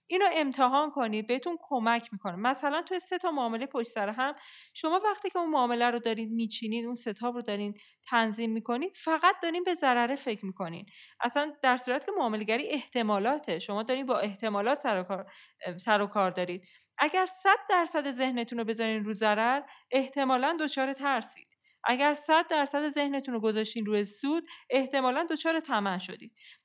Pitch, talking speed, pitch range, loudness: 255 Hz, 160 wpm, 220-295 Hz, -30 LUFS